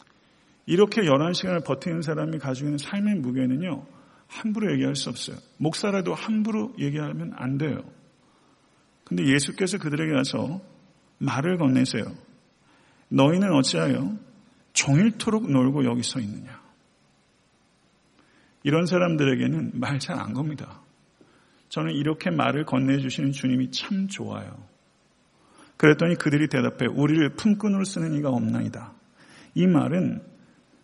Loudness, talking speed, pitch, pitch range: -24 LUFS, 280 characters per minute, 150 Hz, 135-185 Hz